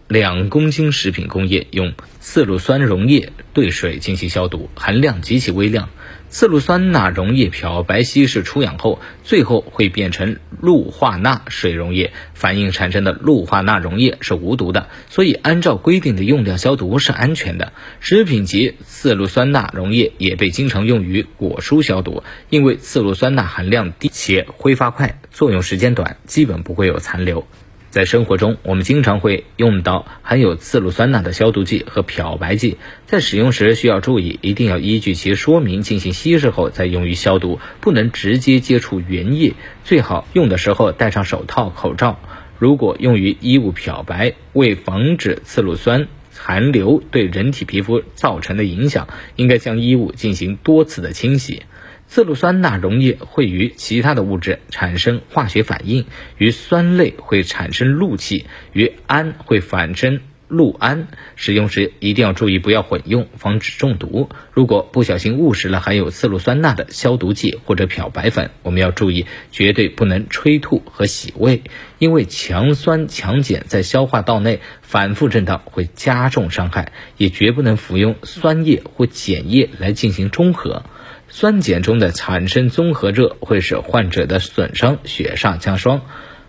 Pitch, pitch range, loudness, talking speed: 110 Hz, 95-135 Hz, -16 LUFS, 260 characters per minute